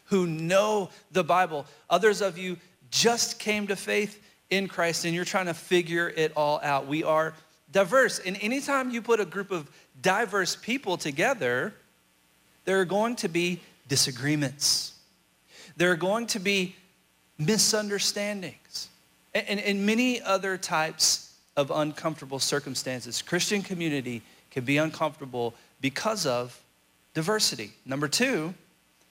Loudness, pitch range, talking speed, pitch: -27 LUFS, 140-200 Hz, 130 wpm, 175 Hz